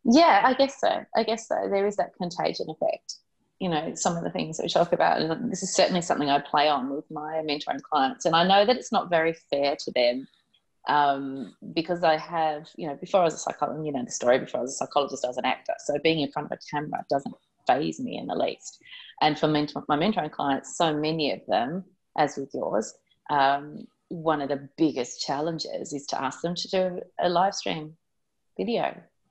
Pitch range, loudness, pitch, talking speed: 145-180 Hz, -26 LUFS, 155 Hz, 225 wpm